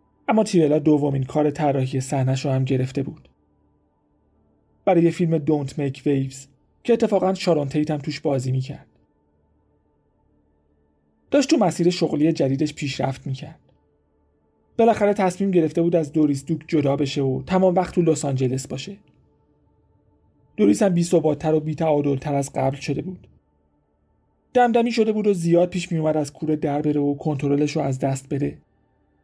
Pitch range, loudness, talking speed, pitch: 100-165 Hz, -21 LUFS, 150 wpm, 145 Hz